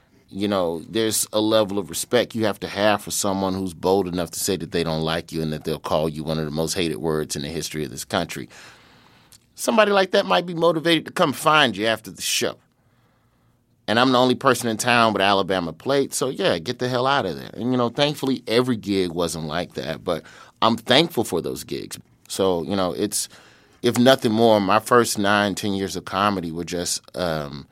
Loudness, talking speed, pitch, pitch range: -21 LUFS, 225 wpm, 100 Hz, 90-125 Hz